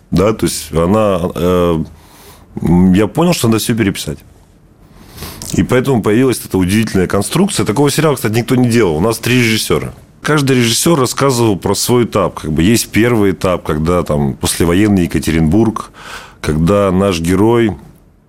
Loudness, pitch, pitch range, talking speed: -13 LUFS, 100 Hz, 90-115 Hz, 150 wpm